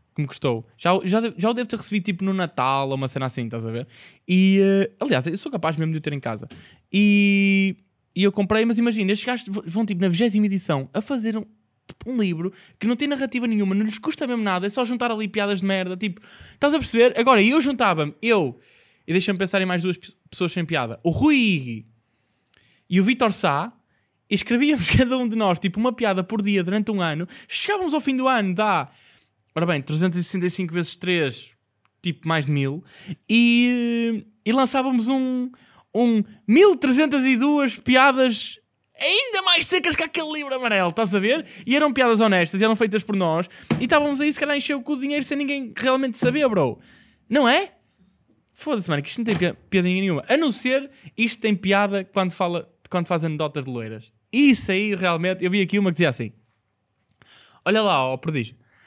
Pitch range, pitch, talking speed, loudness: 170-245 Hz, 200 Hz, 200 wpm, -21 LUFS